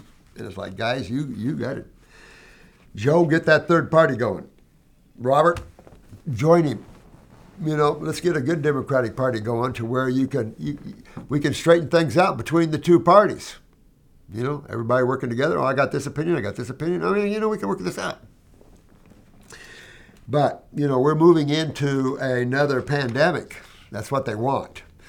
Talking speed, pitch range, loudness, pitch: 180 wpm, 125-160 Hz, -21 LUFS, 140 Hz